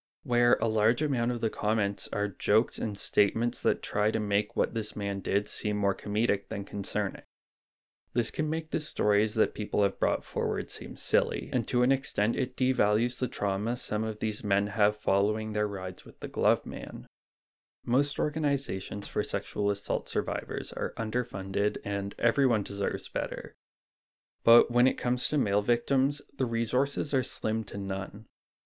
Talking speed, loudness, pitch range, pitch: 170 wpm, -29 LUFS, 100-125 Hz, 110 Hz